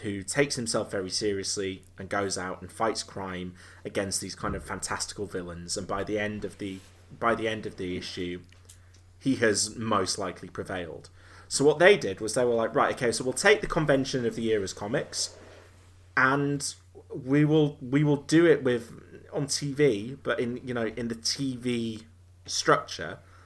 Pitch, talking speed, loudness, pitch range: 105 Hz, 185 wpm, -28 LUFS, 95-125 Hz